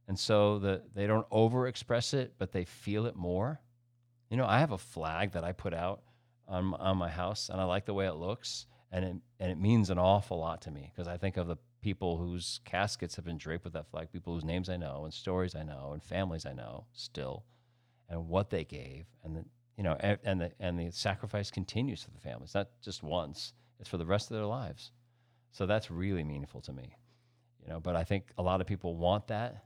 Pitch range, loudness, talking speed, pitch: 90-115 Hz, -35 LUFS, 235 wpm, 95 Hz